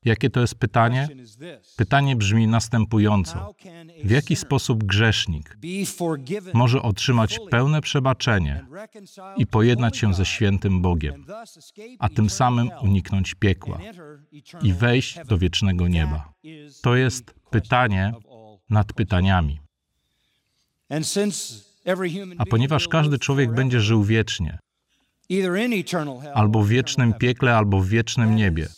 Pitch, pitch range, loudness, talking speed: 120 Hz, 105-145 Hz, -21 LUFS, 105 wpm